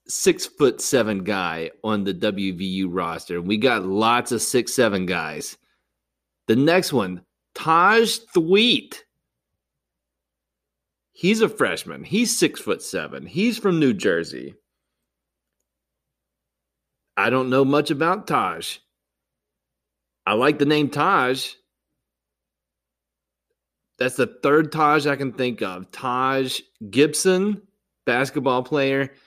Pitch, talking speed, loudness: 110 Hz, 110 wpm, -21 LUFS